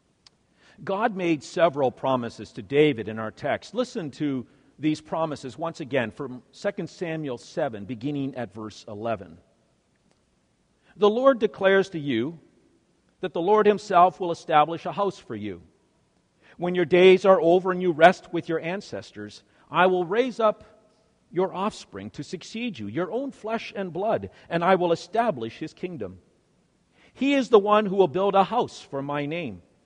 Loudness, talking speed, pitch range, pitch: -24 LUFS, 165 wpm, 140-195 Hz, 170 Hz